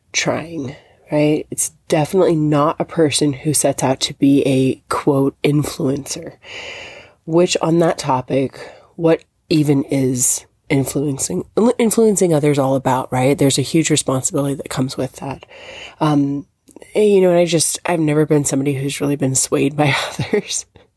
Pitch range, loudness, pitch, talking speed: 135-165 Hz, -17 LUFS, 145 Hz, 150 wpm